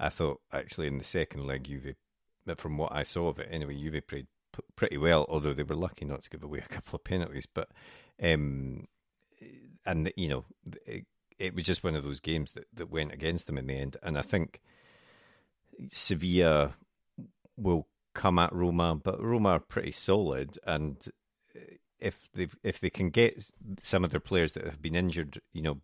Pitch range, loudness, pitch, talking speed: 70-90 Hz, -32 LUFS, 80 Hz, 195 wpm